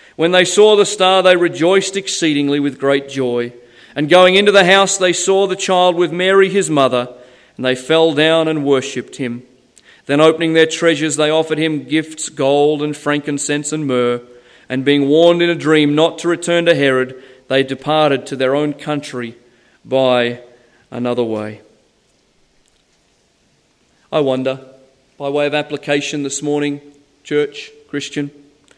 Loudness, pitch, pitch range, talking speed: -14 LUFS, 145 Hz, 130-165 Hz, 155 wpm